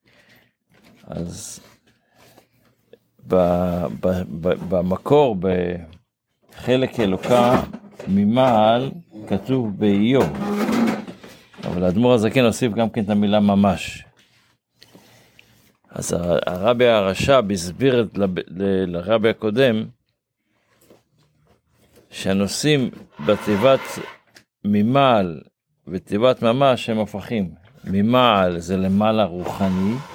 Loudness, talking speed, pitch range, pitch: -19 LUFS, 75 wpm, 95-130 Hz, 110 Hz